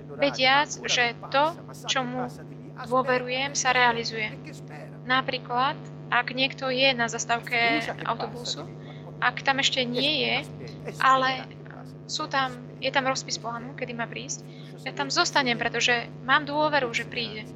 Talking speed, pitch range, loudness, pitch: 130 wpm, 245-275 Hz, -25 LUFS, 260 Hz